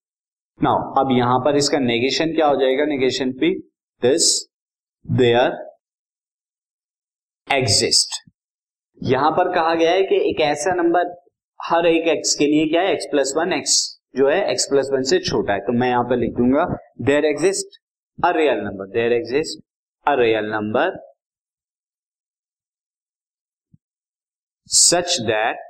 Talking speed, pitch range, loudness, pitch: 135 wpm, 125-175 Hz, -18 LUFS, 150 Hz